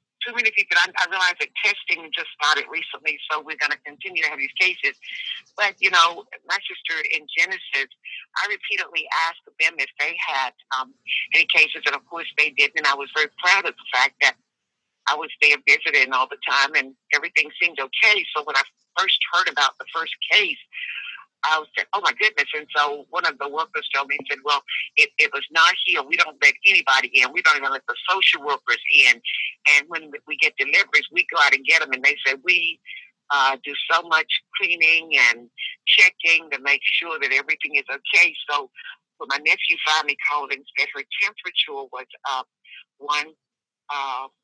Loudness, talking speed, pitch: -19 LUFS, 200 wpm, 155 Hz